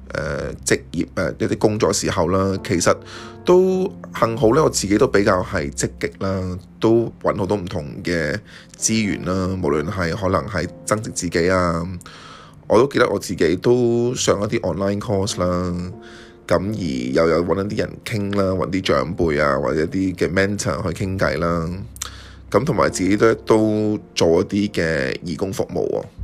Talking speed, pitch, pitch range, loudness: 270 characters per minute, 95 Hz, 90-105 Hz, -20 LUFS